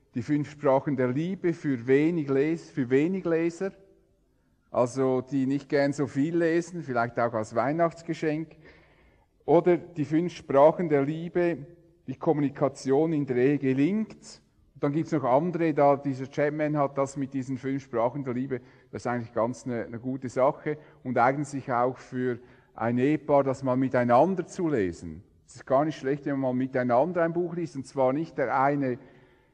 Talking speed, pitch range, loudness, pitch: 170 wpm, 125-155 Hz, -27 LUFS, 140 Hz